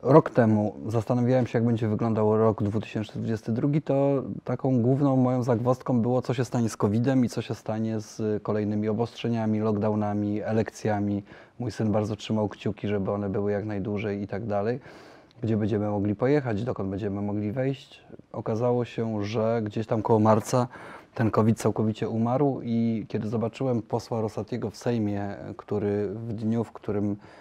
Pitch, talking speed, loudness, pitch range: 110 Hz, 160 wpm, -27 LUFS, 105-120 Hz